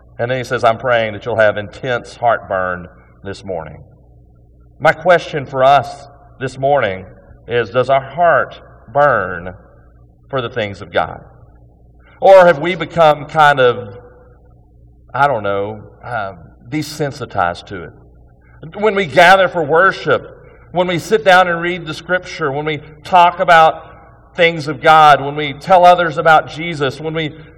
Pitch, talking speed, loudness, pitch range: 140 Hz, 150 wpm, -13 LUFS, 100-160 Hz